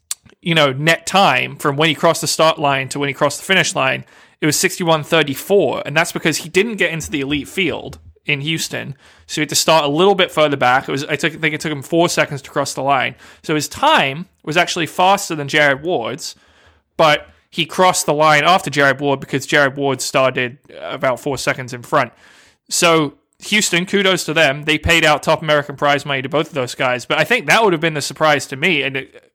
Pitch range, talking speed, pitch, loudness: 140-165 Hz, 235 wpm, 155 Hz, -16 LUFS